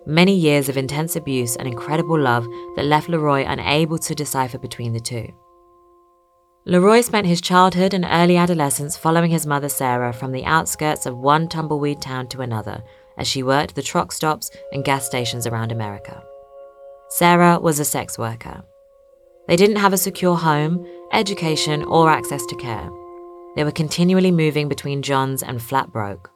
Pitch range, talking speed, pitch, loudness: 130-175 Hz, 165 wpm, 150 Hz, -19 LUFS